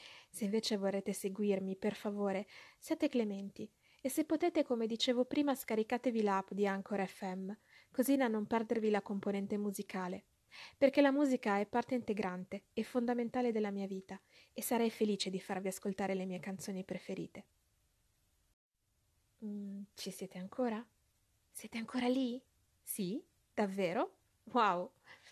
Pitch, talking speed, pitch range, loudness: 210 Hz, 135 wpm, 195-245 Hz, -37 LUFS